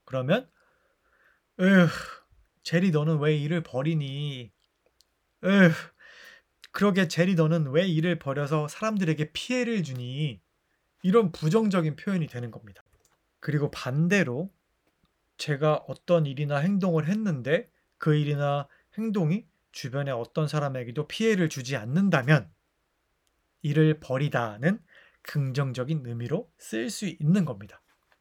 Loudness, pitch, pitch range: -27 LUFS, 155 Hz, 140-185 Hz